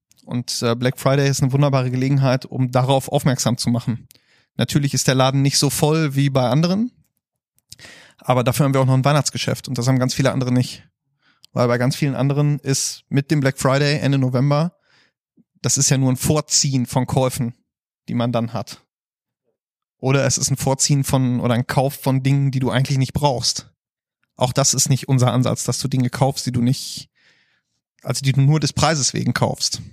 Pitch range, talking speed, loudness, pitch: 125-140 Hz, 195 wpm, -19 LUFS, 135 Hz